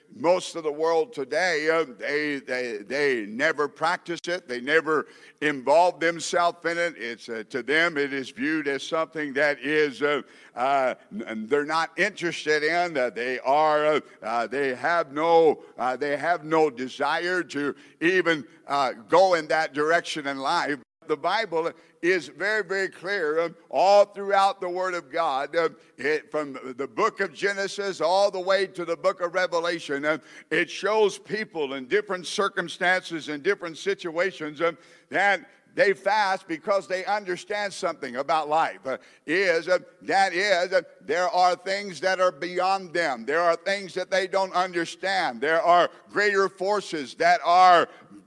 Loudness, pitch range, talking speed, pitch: -25 LUFS, 155-195 Hz, 165 wpm, 170 Hz